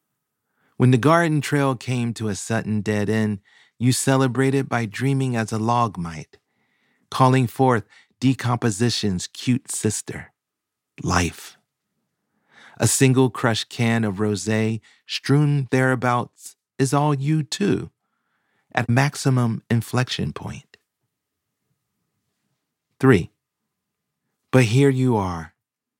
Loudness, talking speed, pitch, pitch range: -21 LUFS, 105 wpm, 120 Hz, 110-135 Hz